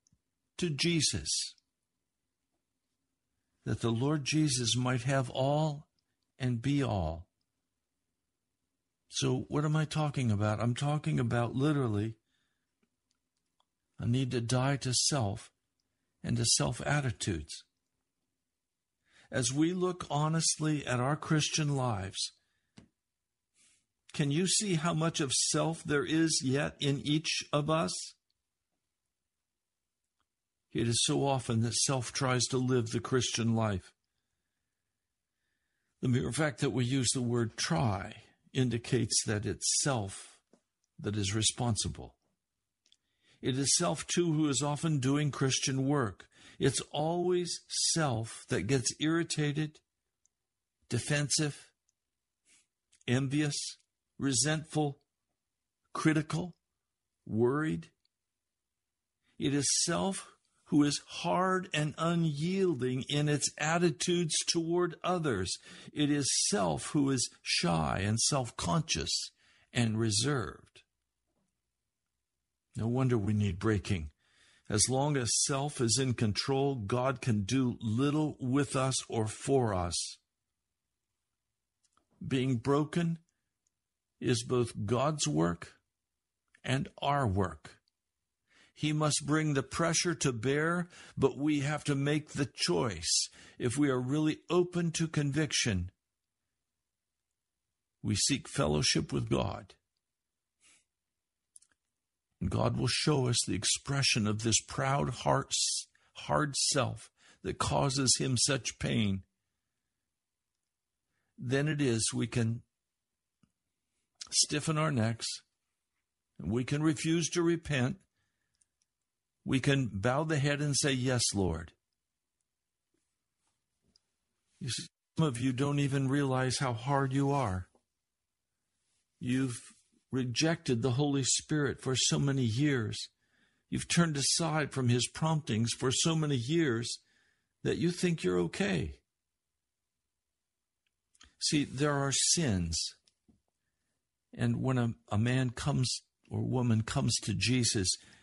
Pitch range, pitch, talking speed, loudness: 115-150 Hz, 130 Hz, 110 wpm, -31 LUFS